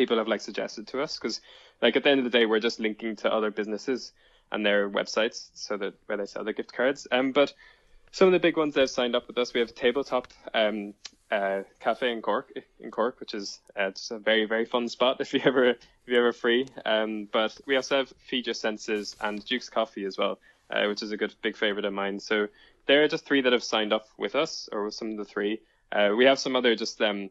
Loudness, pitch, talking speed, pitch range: -27 LUFS, 115 Hz, 255 wpm, 105-130 Hz